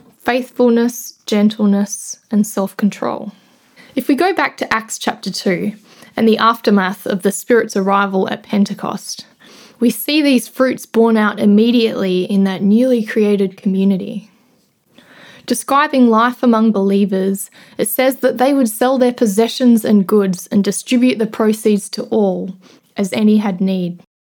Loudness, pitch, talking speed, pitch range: -15 LUFS, 220 Hz, 140 wpm, 200-245 Hz